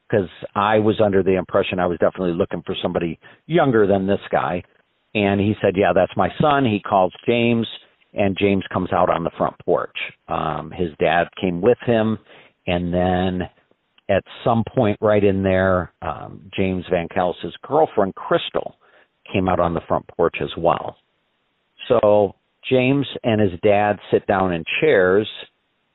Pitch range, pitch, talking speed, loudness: 90-105 Hz, 100 Hz, 165 wpm, -20 LUFS